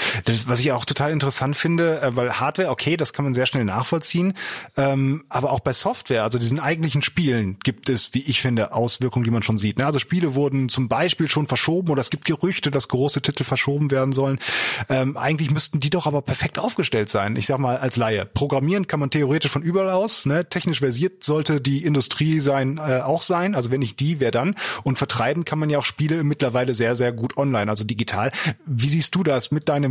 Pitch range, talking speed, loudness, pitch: 125-155 Hz, 210 wpm, -21 LUFS, 140 Hz